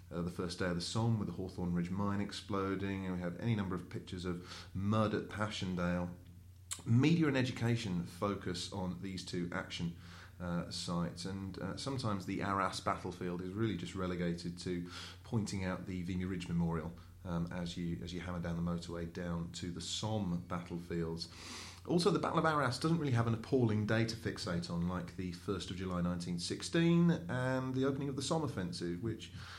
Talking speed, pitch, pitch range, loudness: 190 wpm, 90 Hz, 90-105 Hz, -37 LUFS